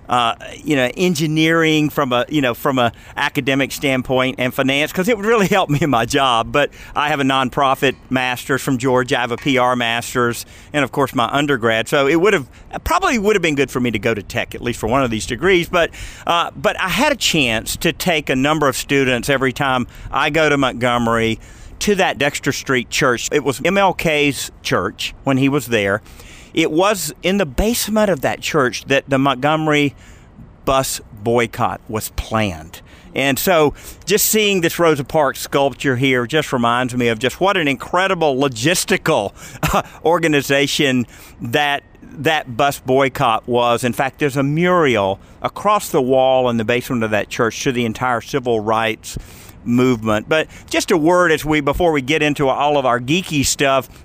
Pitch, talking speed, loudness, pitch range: 135 Hz, 190 wpm, -17 LUFS, 120-155 Hz